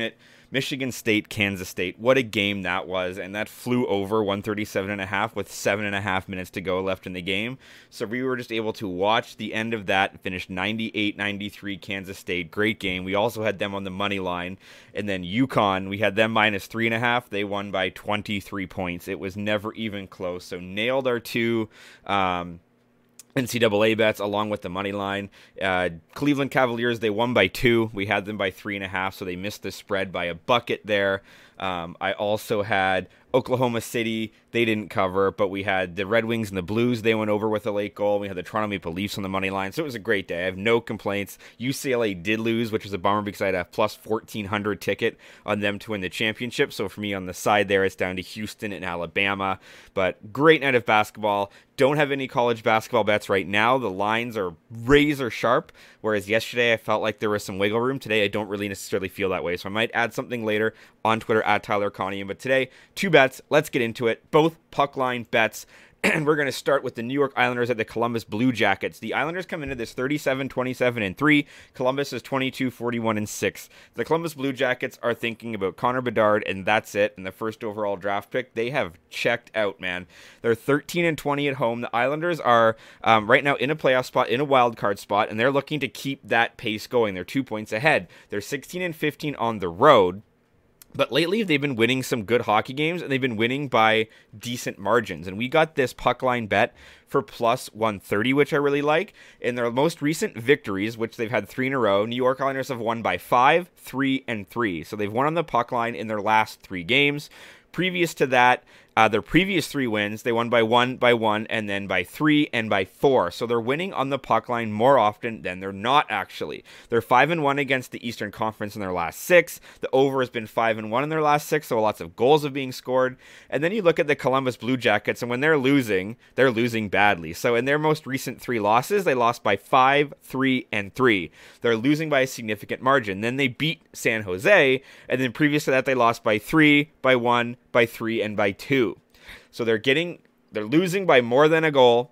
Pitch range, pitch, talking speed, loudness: 100-130 Hz, 115 Hz, 225 wpm, -23 LUFS